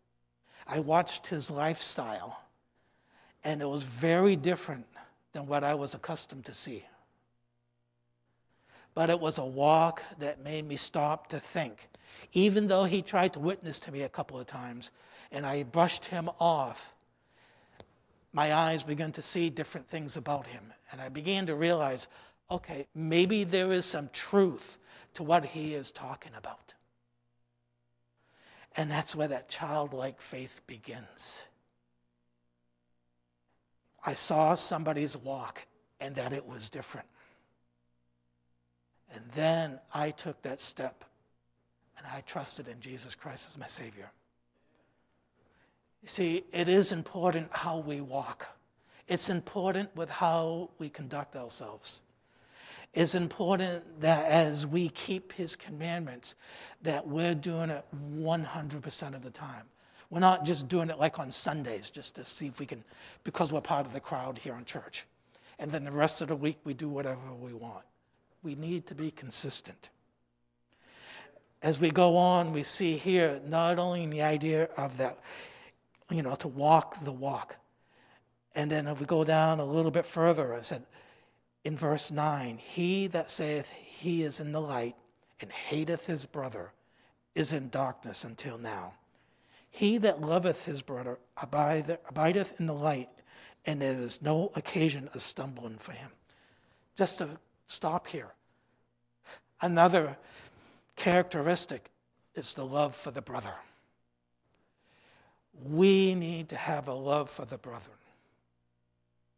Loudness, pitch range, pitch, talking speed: -32 LUFS, 125-165 Hz, 150 Hz, 145 wpm